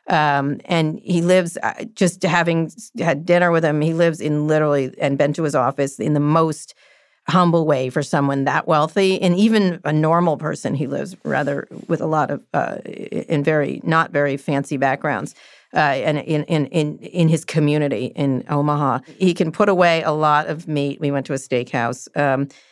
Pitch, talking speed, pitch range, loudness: 155 Hz, 190 wpm, 145-170 Hz, -19 LUFS